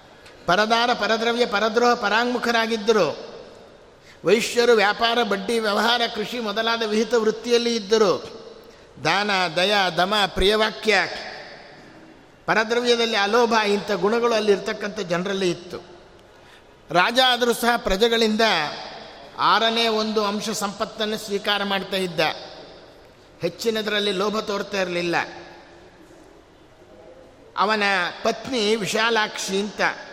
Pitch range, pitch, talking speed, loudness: 200-230 Hz, 215 Hz, 85 wpm, -21 LUFS